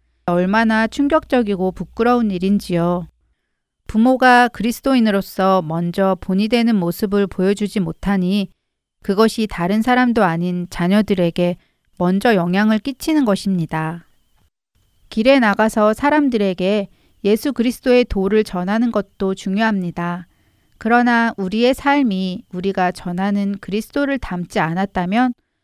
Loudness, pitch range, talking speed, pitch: -17 LUFS, 185-235 Hz, 290 characters per minute, 205 Hz